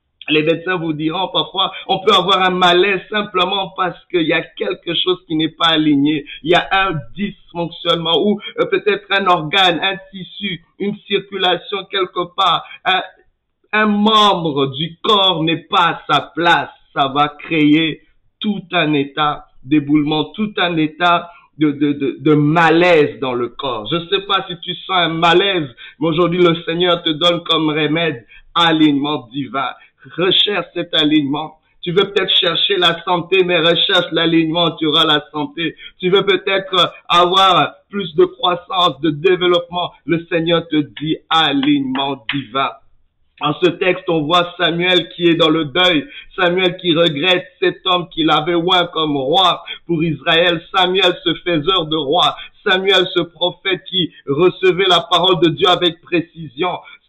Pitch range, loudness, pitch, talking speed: 155-185 Hz, -15 LUFS, 170 Hz, 160 wpm